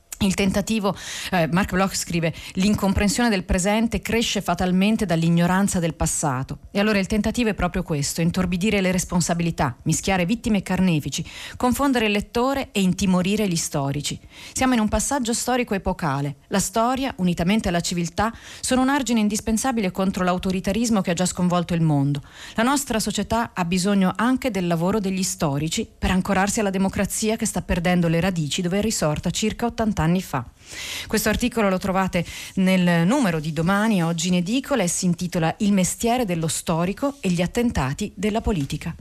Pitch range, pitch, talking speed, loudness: 175-215 Hz, 190 Hz, 165 wpm, -22 LUFS